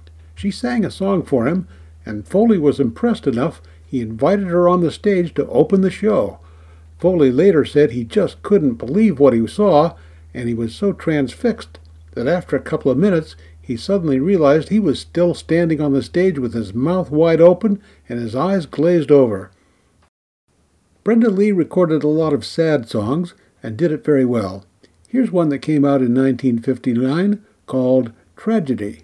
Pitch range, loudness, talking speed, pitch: 115-180 Hz, -17 LUFS, 175 wpm, 140 Hz